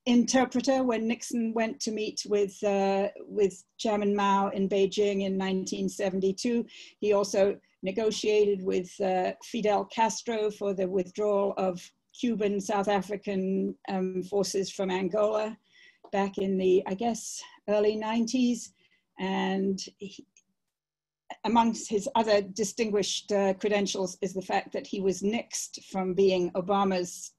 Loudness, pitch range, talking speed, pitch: -28 LUFS, 190-215 Hz, 125 wpm, 200 Hz